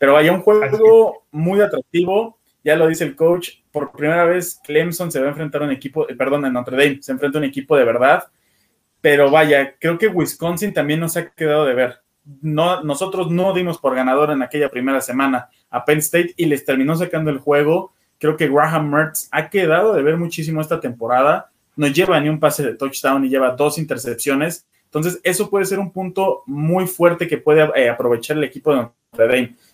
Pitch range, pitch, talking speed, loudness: 140-170 Hz, 155 Hz, 205 wpm, -17 LUFS